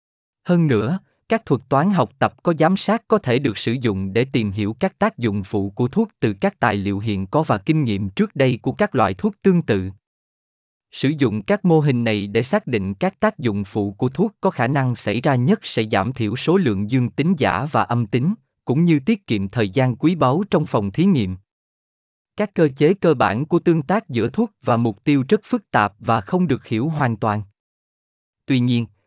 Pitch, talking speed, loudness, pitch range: 125 Hz, 225 wpm, -20 LUFS, 105-175 Hz